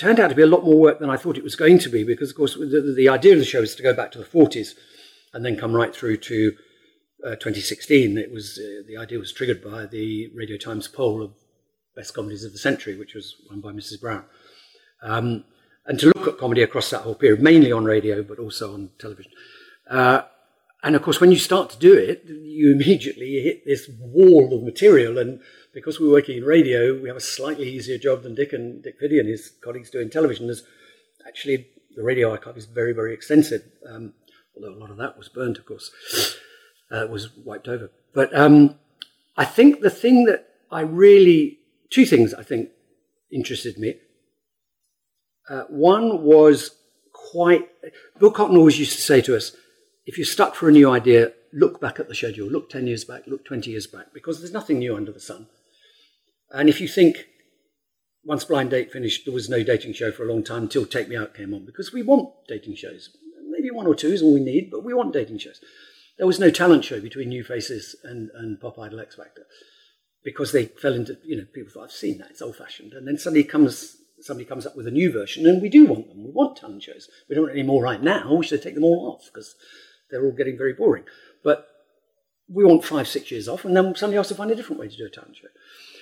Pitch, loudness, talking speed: 155 Hz, -19 LUFS, 225 wpm